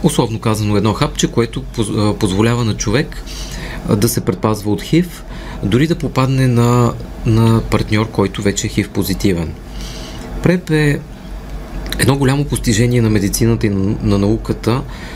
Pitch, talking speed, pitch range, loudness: 110 Hz, 135 wpm, 105-130 Hz, -16 LUFS